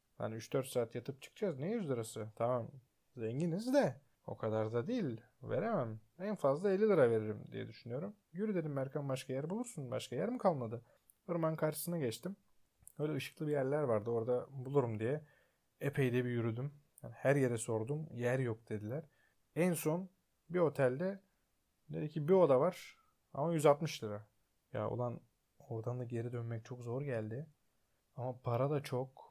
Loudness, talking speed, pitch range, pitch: -38 LUFS, 165 wpm, 115-155 Hz, 130 Hz